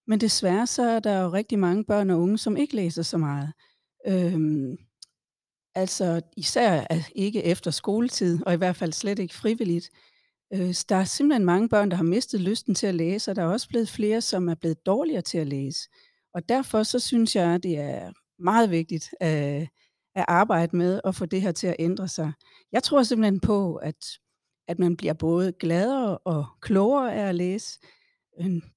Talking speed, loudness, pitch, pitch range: 195 wpm, -25 LUFS, 185 Hz, 170-215 Hz